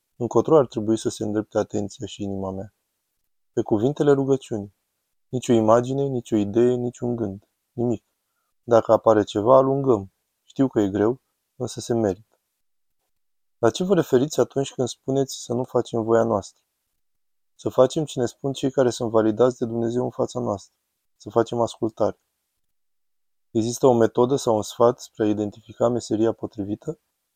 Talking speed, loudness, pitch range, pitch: 160 wpm, -23 LUFS, 105-125 Hz, 115 Hz